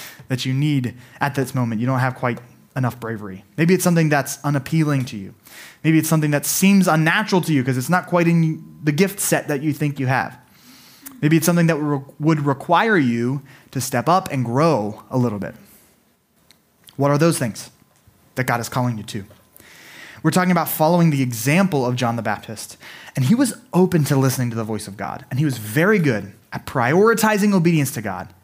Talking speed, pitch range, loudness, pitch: 205 wpm, 120-165 Hz, -19 LUFS, 140 Hz